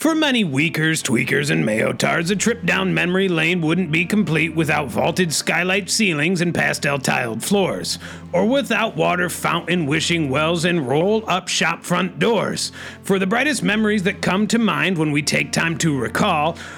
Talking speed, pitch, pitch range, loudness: 170 wpm, 175 Hz, 160-200 Hz, -19 LUFS